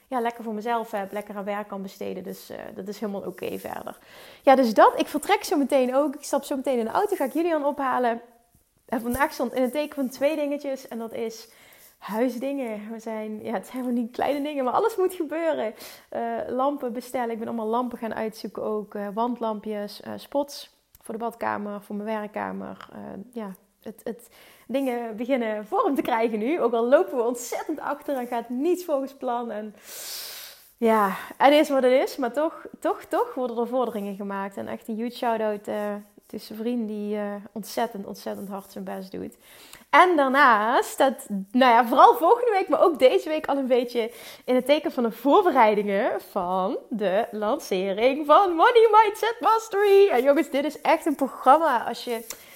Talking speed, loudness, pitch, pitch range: 200 wpm, -24 LUFS, 245 Hz, 220-290 Hz